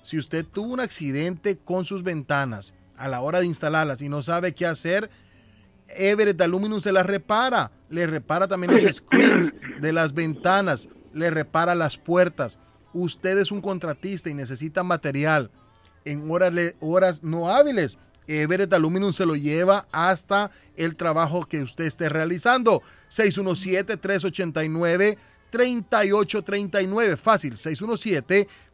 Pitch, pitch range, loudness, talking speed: 175 Hz, 155-195 Hz, -23 LUFS, 130 wpm